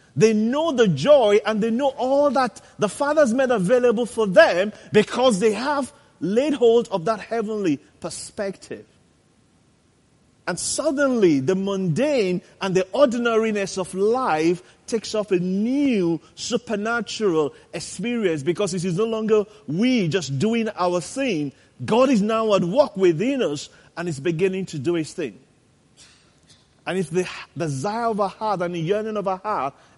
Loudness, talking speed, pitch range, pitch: -21 LUFS, 150 wpm, 185-235 Hz, 210 Hz